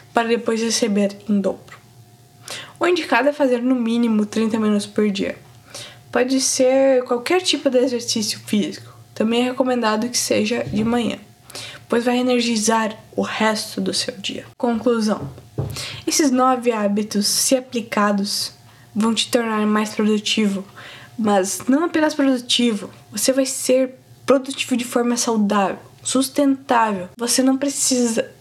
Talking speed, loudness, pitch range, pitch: 135 wpm, -19 LUFS, 210-255 Hz, 235 Hz